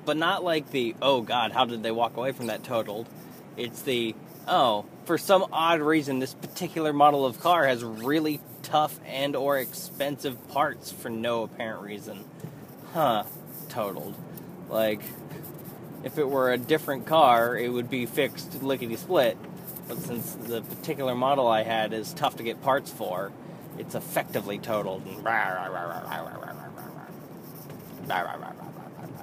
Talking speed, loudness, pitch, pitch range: 140 wpm, -27 LUFS, 130 Hz, 115-150 Hz